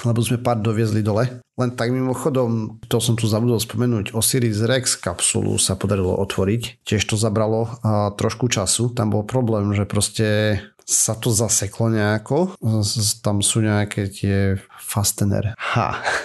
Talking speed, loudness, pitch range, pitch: 150 wpm, -20 LUFS, 105-120 Hz, 110 Hz